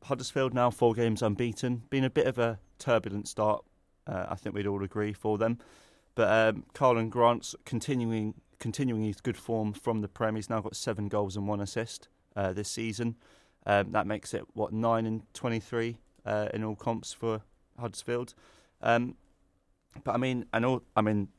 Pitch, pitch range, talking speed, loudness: 110 Hz, 105-120 Hz, 185 wpm, -31 LUFS